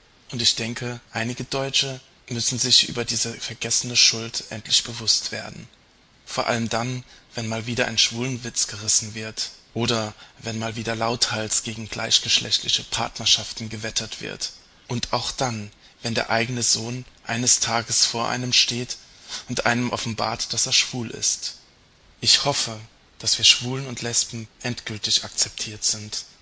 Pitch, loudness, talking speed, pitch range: 115 Hz, -22 LUFS, 145 wpm, 110-120 Hz